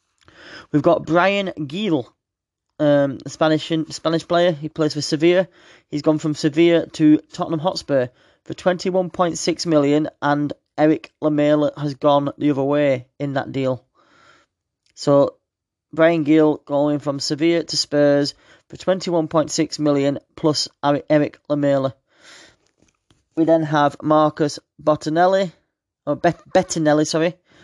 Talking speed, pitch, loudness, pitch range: 120 wpm, 155 Hz, -19 LUFS, 145-165 Hz